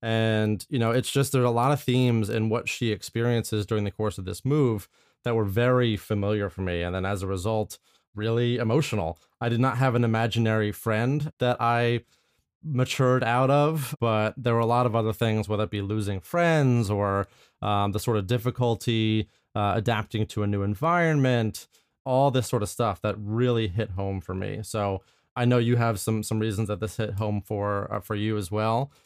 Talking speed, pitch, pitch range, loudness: 205 wpm, 110 Hz, 105-120 Hz, -26 LUFS